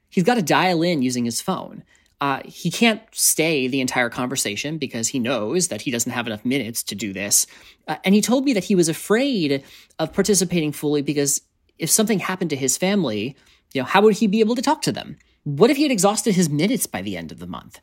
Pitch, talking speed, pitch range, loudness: 165 Hz, 235 wpm, 135-210 Hz, -20 LUFS